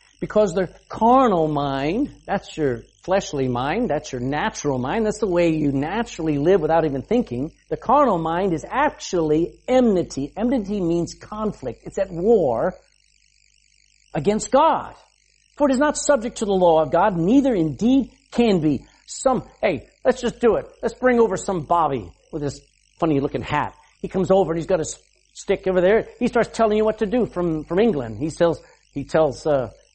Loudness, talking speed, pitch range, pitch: -21 LUFS, 175 wpm, 150-225 Hz, 180 Hz